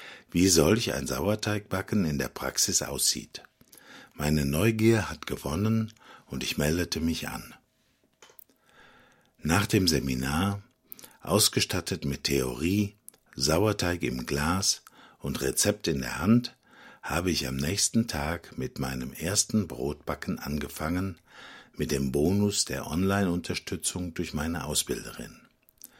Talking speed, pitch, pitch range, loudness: 115 wpm, 85 Hz, 75-100 Hz, -28 LUFS